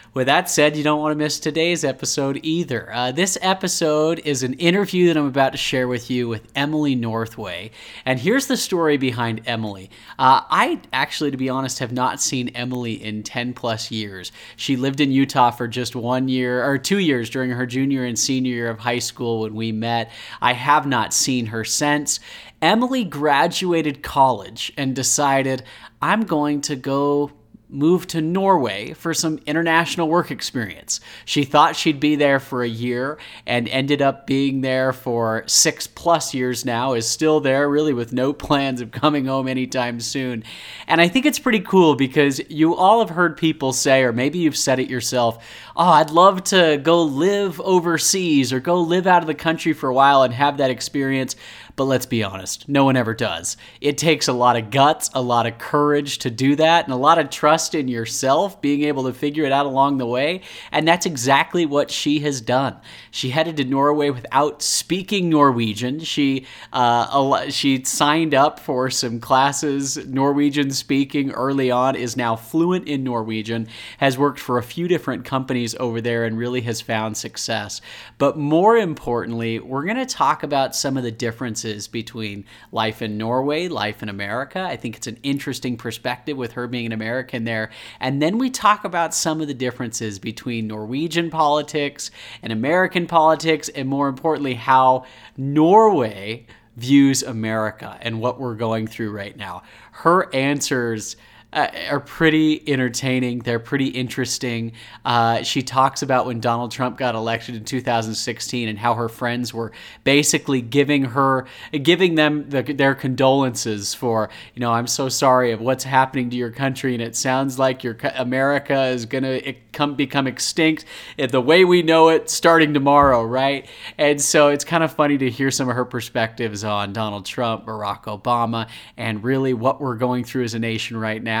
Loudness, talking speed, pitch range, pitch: -19 LUFS, 180 wpm, 120-150 Hz, 130 Hz